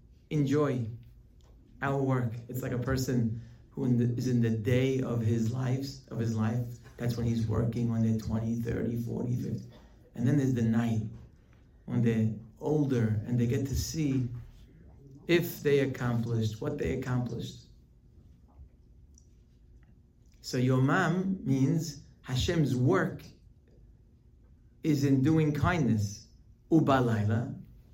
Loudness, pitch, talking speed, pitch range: -30 LUFS, 120 Hz, 130 wpm, 115-135 Hz